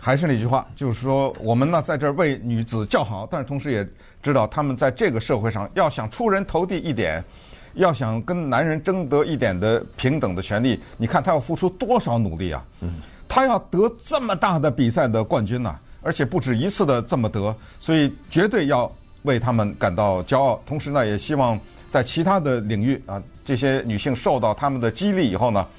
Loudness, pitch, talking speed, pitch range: -22 LUFS, 130 Hz, 305 characters per minute, 110-155 Hz